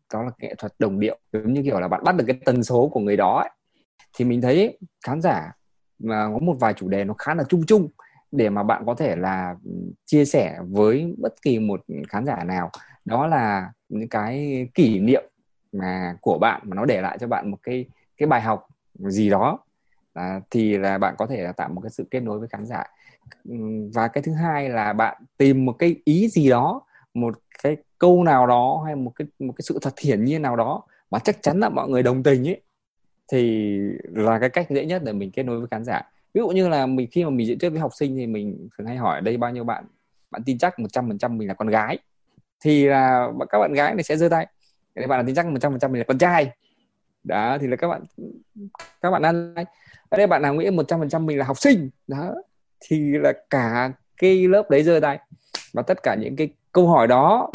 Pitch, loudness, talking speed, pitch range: 135 Hz, -22 LUFS, 235 wpm, 115-165 Hz